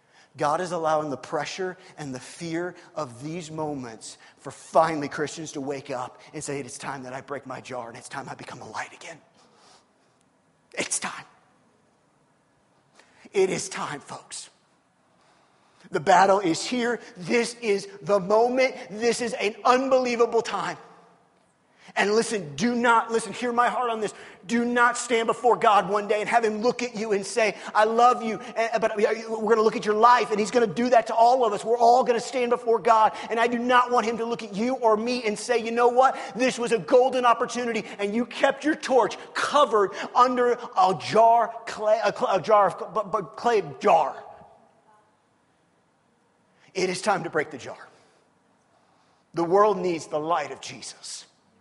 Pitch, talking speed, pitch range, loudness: 220 Hz, 185 wpm, 185-240 Hz, -23 LUFS